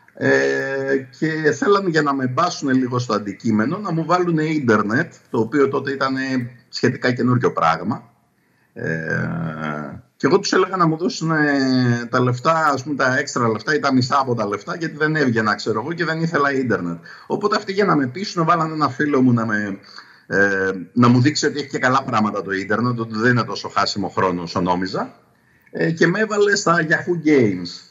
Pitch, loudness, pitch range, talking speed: 135 Hz, -19 LUFS, 110-155 Hz, 190 wpm